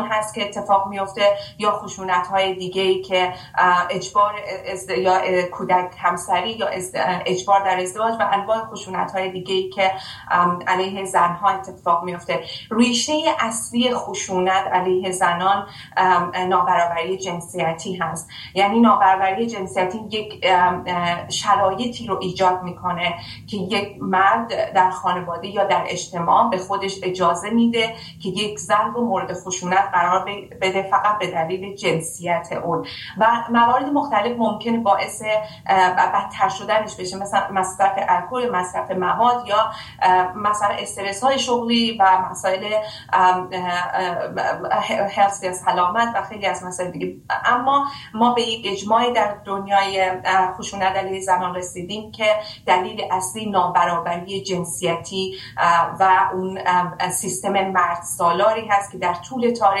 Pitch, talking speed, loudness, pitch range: 190 Hz, 125 wpm, -20 LUFS, 180-210 Hz